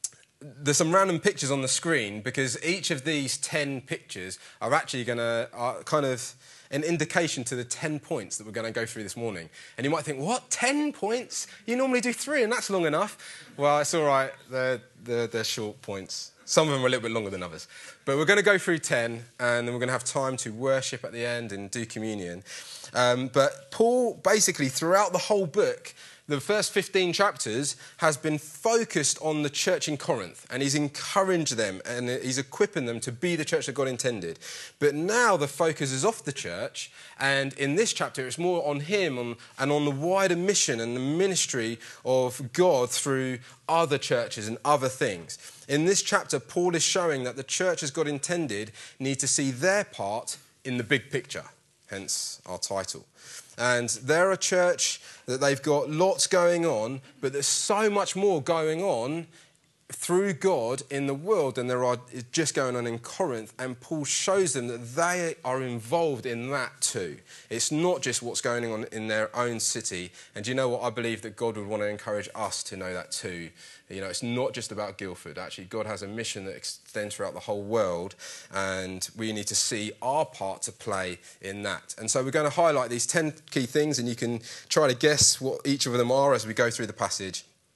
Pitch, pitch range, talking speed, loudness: 135 Hz, 120-165 Hz, 210 wpm, -27 LUFS